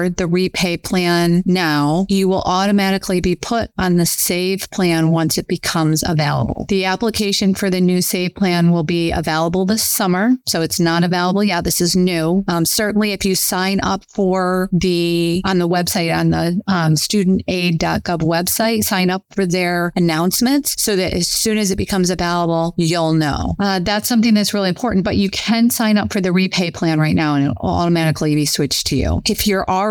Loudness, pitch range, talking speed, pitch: -16 LUFS, 170-195 Hz, 190 wpm, 180 Hz